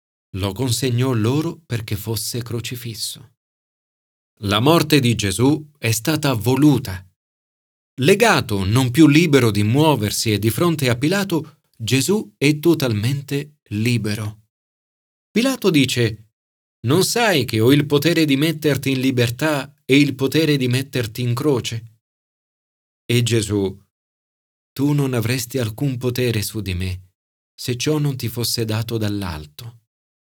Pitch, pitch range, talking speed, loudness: 125 Hz, 110-145 Hz, 125 wpm, -19 LUFS